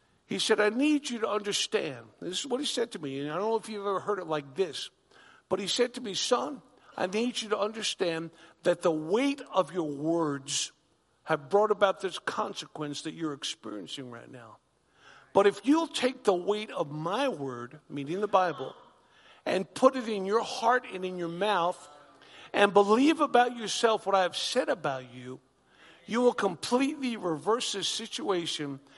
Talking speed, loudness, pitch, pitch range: 185 wpm, -29 LUFS, 205 Hz, 165-240 Hz